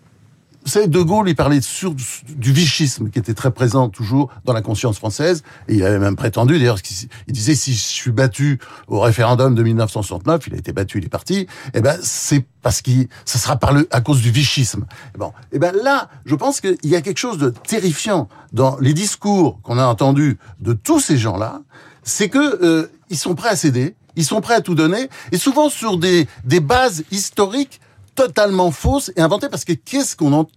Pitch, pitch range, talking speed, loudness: 140 Hz, 120-180 Hz, 205 wpm, -17 LUFS